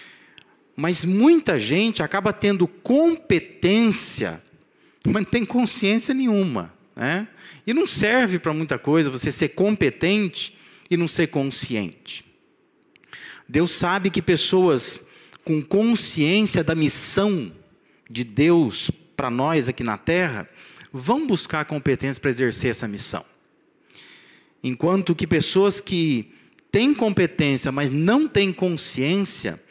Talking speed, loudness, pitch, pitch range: 115 wpm, -21 LUFS, 175 Hz, 150-200 Hz